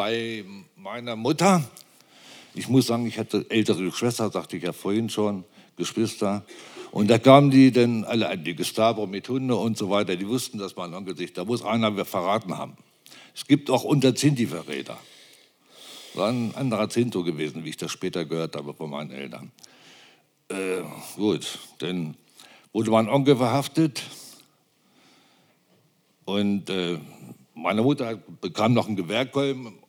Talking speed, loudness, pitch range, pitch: 155 wpm, -24 LUFS, 95-120 Hz, 110 Hz